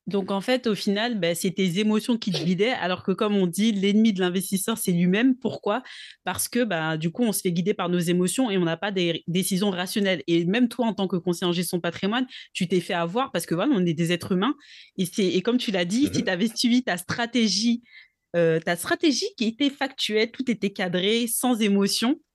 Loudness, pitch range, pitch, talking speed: -24 LUFS, 180-235 Hz, 200 Hz, 235 wpm